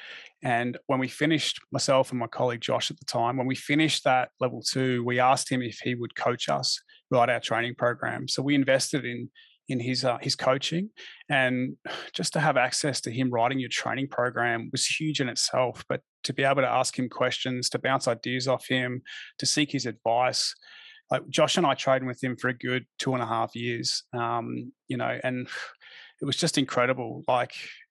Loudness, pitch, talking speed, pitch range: -27 LUFS, 130 Hz, 205 wpm, 120-140 Hz